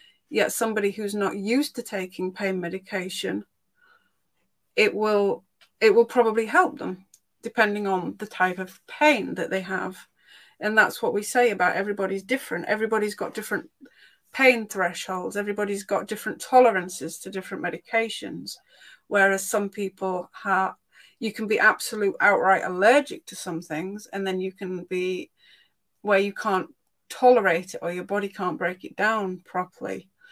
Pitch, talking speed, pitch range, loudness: 200 Hz, 150 wpm, 185-225 Hz, -24 LUFS